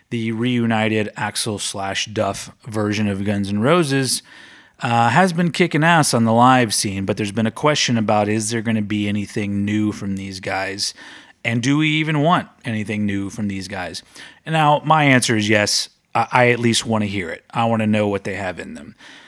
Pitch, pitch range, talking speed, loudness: 110 Hz, 105-125 Hz, 210 wpm, -19 LUFS